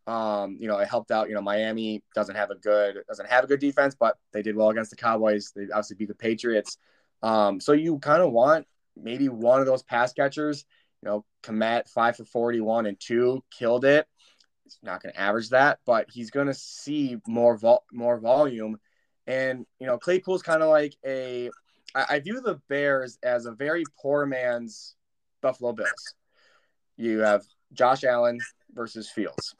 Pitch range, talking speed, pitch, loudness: 110-140 Hz, 190 wpm, 120 Hz, -25 LUFS